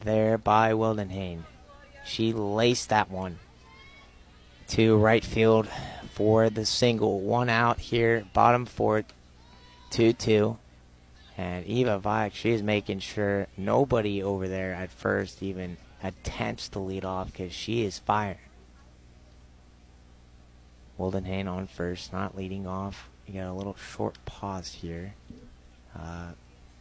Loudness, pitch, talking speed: -27 LUFS, 95 Hz, 120 wpm